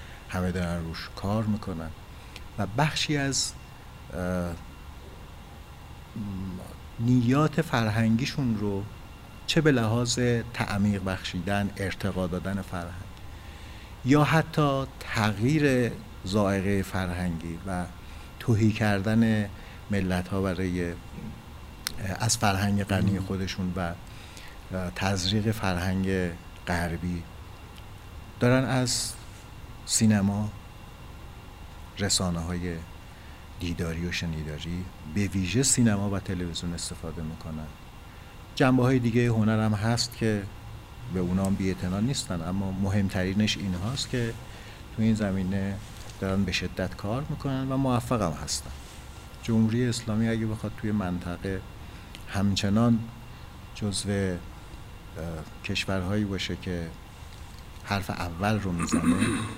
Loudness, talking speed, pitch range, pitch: -28 LUFS, 95 wpm, 90-110 Hz, 95 Hz